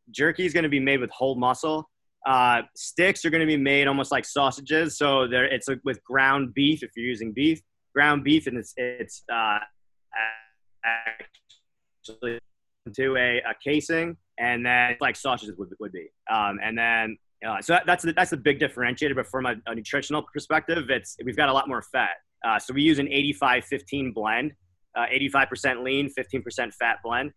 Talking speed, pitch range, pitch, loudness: 185 wpm, 120-145 Hz, 135 Hz, -24 LUFS